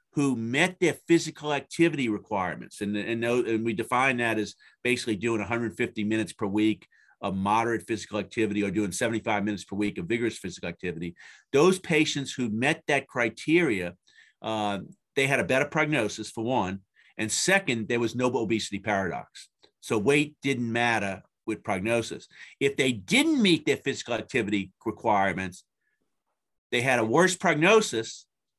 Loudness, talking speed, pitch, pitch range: -26 LUFS, 155 wpm, 115 Hz, 105-140 Hz